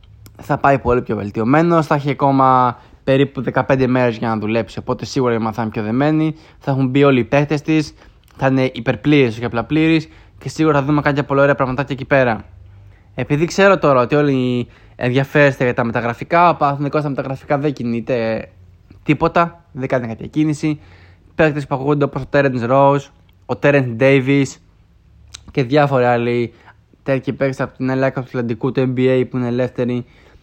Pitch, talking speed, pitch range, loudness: 130 Hz, 170 wpm, 115-145 Hz, -17 LUFS